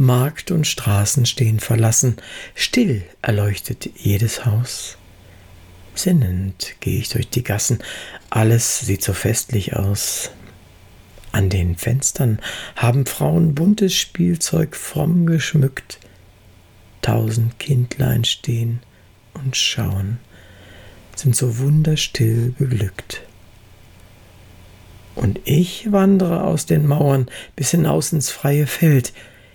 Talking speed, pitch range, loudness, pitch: 100 wpm, 100-140 Hz, -18 LUFS, 115 Hz